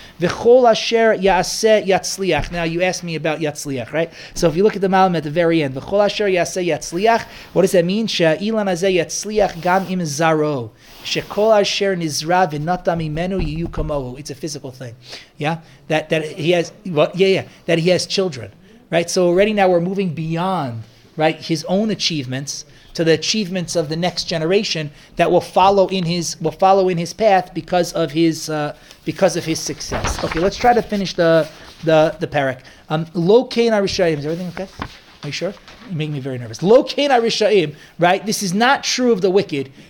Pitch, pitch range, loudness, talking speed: 175 Hz, 155-195 Hz, -18 LUFS, 190 wpm